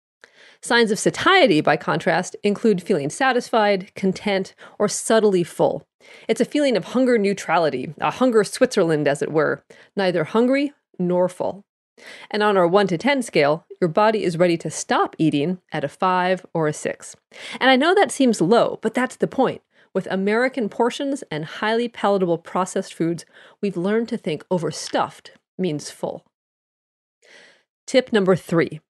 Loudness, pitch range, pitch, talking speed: -20 LUFS, 180-235 Hz, 200 Hz, 160 wpm